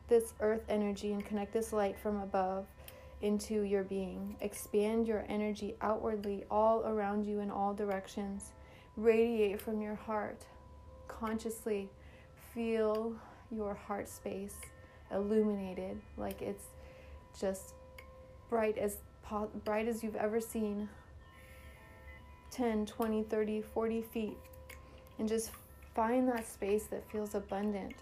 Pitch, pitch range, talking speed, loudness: 210 Hz, 195-220 Hz, 120 wpm, -37 LUFS